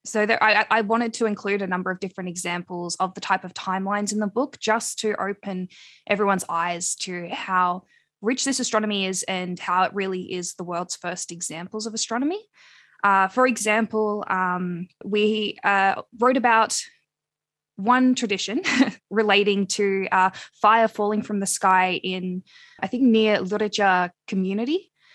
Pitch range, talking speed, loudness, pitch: 185-220 Hz, 155 wpm, -23 LUFS, 200 Hz